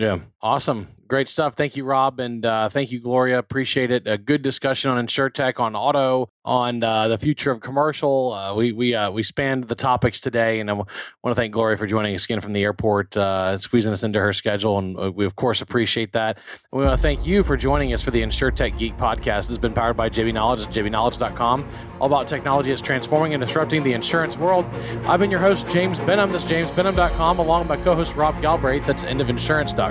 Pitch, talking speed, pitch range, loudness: 125 Hz, 230 wpm, 110-145 Hz, -21 LUFS